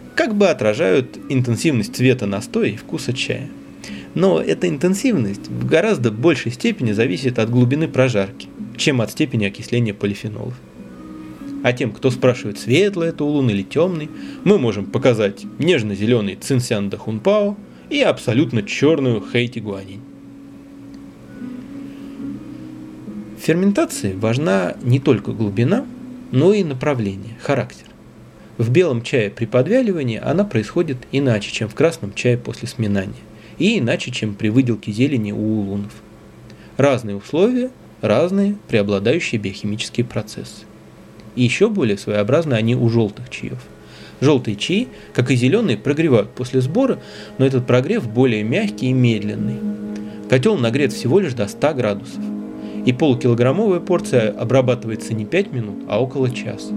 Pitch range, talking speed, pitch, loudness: 105-140 Hz, 130 wpm, 120 Hz, -18 LUFS